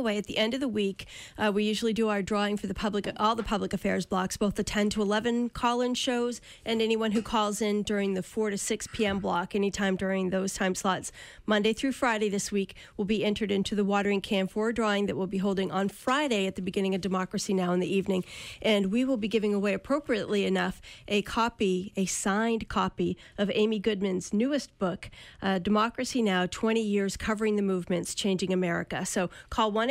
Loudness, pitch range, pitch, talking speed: -29 LUFS, 195-220 Hz, 205 Hz, 210 wpm